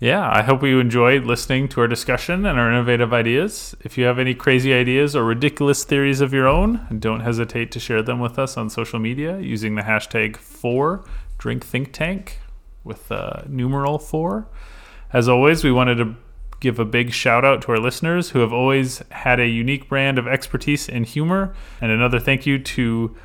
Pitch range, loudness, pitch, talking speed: 120-140 Hz, -19 LUFS, 125 Hz, 195 wpm